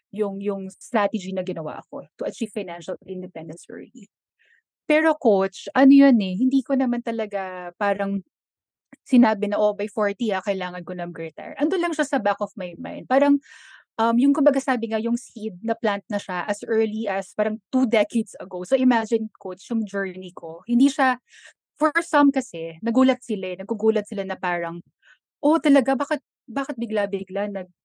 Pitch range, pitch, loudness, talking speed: 190-260 Hz, 215 Hz, -23 LUFS, 180 wpm